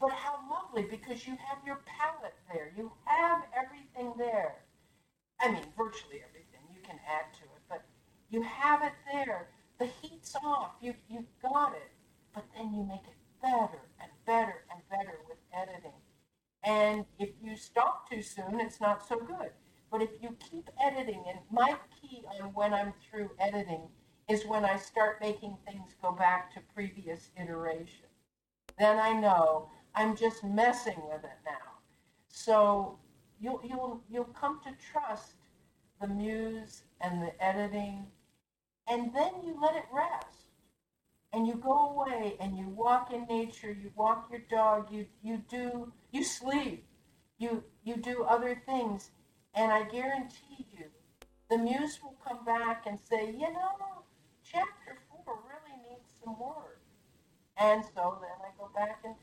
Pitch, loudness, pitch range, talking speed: 225 Hz, -34 LUFS, 200-255 Hz, 160 wpm